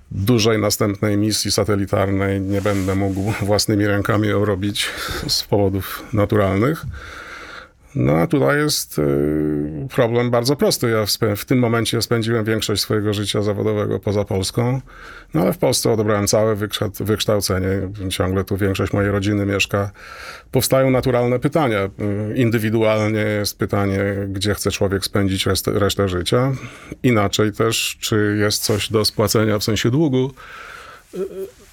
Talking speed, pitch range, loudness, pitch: 135 wpm, 100-115 Hz, -19 LUFS, 105 Hz